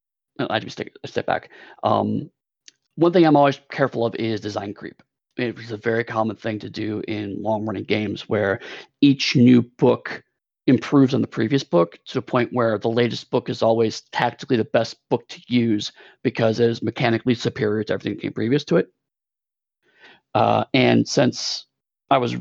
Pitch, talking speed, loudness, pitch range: 115 Hz, 175 wpm, -21 LUFS, 110-125 Hz